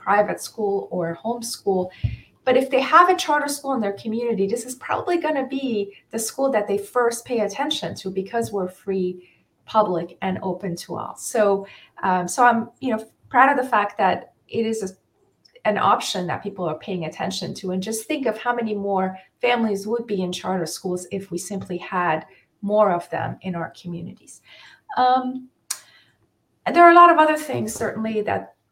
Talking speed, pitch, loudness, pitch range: 190 wpm, 205 Hz, -22 LUFS, 185-245 Hz